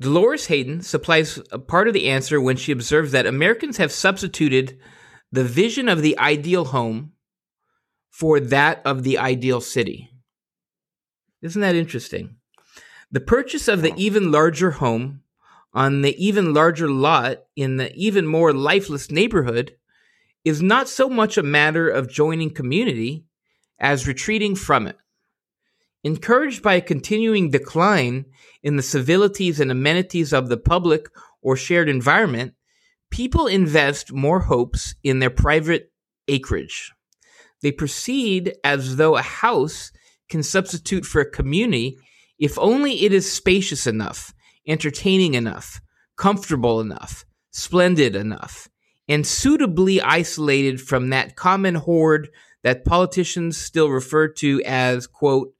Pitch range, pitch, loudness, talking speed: 135-185 Hz, 155 Hz, -19 LUFS, 130 wpm